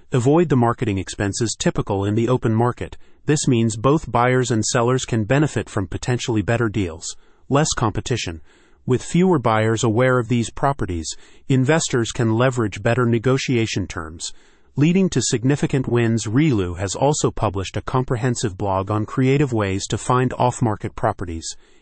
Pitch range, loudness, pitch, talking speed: 105-130 Hz, -20 LUFS, 120 Hz, 150 wpm